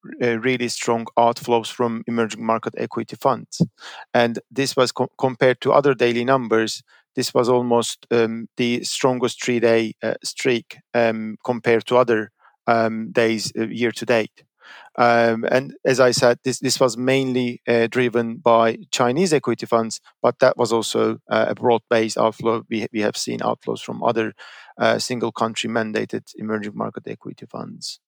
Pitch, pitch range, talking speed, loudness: 120 Hz, 115-125 Hz, 160 wpm, -20 LUFS